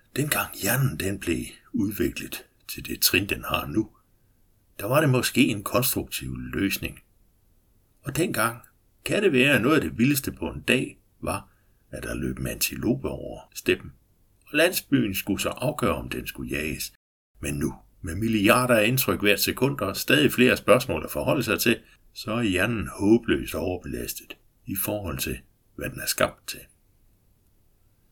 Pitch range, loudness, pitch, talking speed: 95-115 Hz, -25 LUFS, 100 Hz, 165 wpm